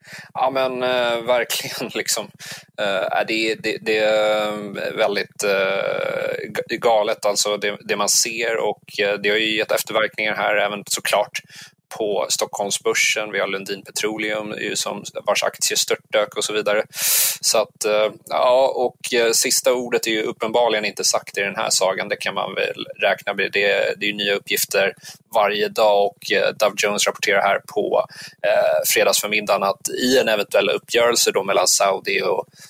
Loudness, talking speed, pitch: -19 LUFS, 155 wpm, 110 Hz